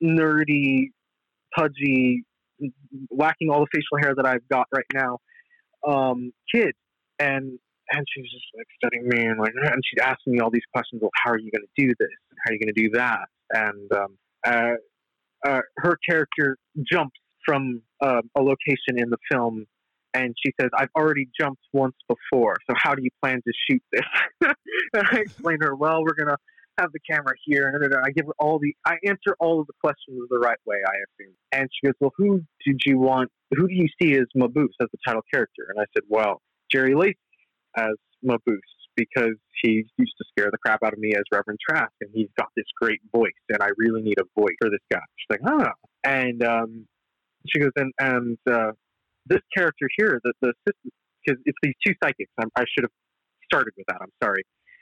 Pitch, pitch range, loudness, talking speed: 135 Hz, 120-155 Hz, -23 LUFS, 205 wpm